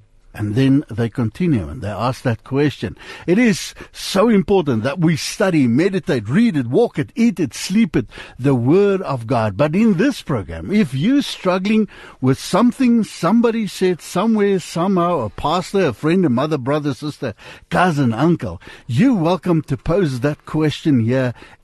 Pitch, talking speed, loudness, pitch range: 155 Hz, 165 wpm, -18 LUFS, 130-195 Hz